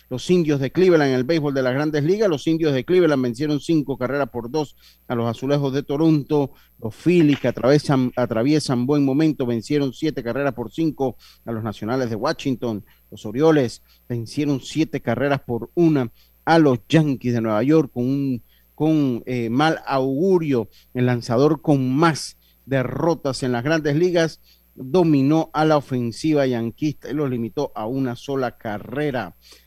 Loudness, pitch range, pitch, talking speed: -21 LUFS, 120-150 Hz, 135 Hz, 165 wpm